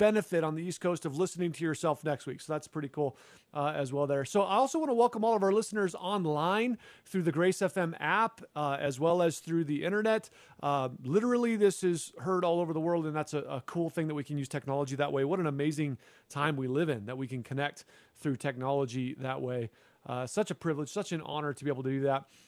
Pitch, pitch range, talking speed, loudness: 155 Hz, 140-185 Hz, 245 wpm, -32 LUFS